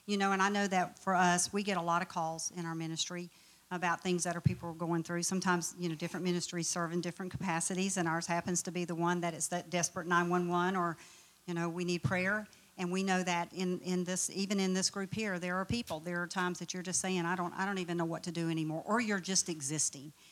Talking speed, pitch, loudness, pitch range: 260 wpm, 175 Hz, -34 LUFS, 170-185 Hz